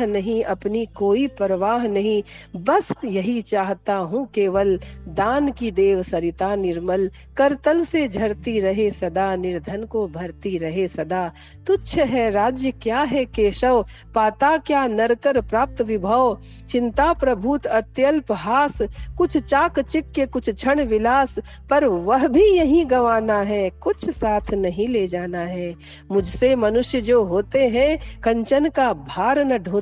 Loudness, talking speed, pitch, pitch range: -20 LUFS, 135 wpm, 225 Hz, 200-270 Hz